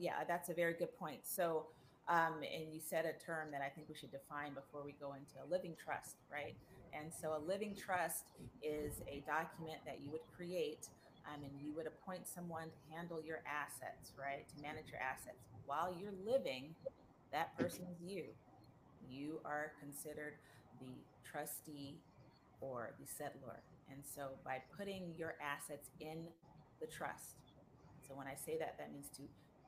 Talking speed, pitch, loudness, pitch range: 175 wpm, 150 Hz, -47 LUFS, 140-165 Hz